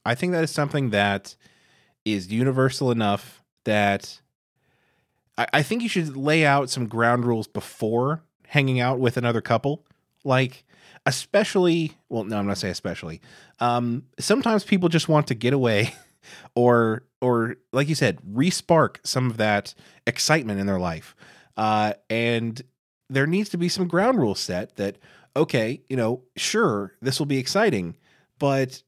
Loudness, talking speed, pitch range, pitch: -23 LUFS, 155 wpm, 115-150 Hz, 130 Hz